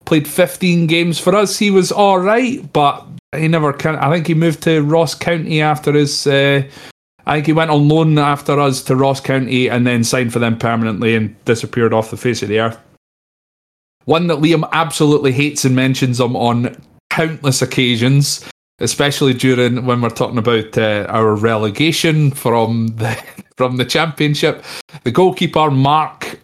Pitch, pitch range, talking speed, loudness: 140 Hz, 120-160 Hz, 170 wpm, -14 LUFS